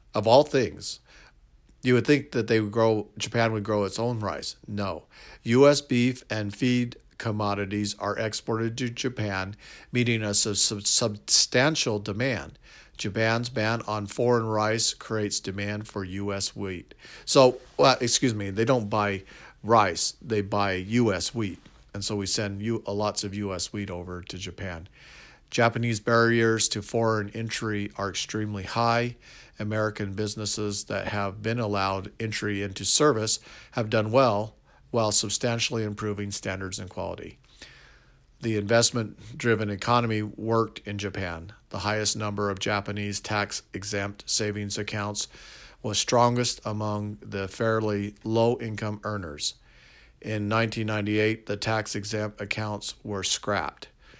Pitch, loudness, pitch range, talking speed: 105 Hz, -26 LUFS, 100-115 Hz, 135 wpm